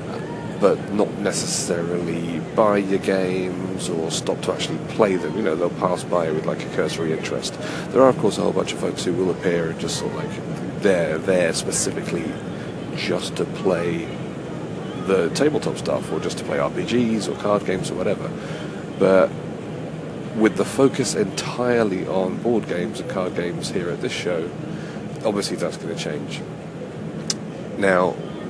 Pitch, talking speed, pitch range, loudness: 95 Hz, 165 wpm, 95-110 Hz, -23 LUFS